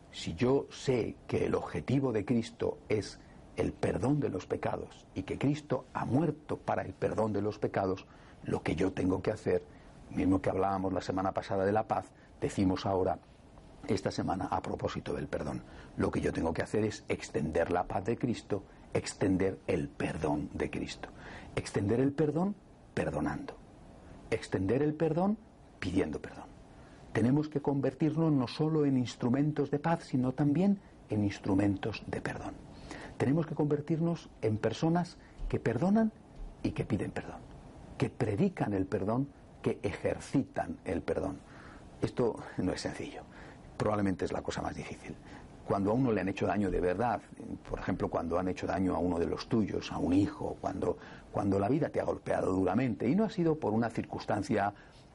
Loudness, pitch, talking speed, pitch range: -33 LUFS, 130 Hz, 170 wpm, 100-150 Hz